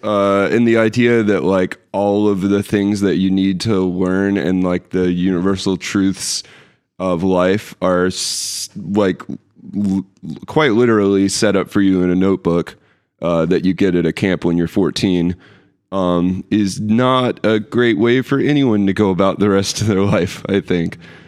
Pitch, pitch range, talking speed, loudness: 95 Hz, 90-105 Hz, 180 wpm, -16 LUFS